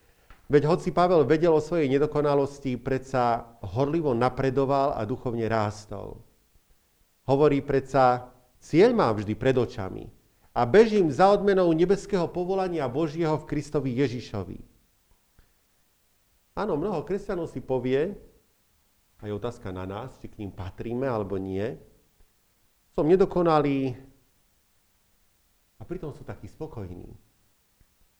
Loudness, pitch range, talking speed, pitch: -25 LUFS, 110-155 Hz, 110 wpm, 130 Hz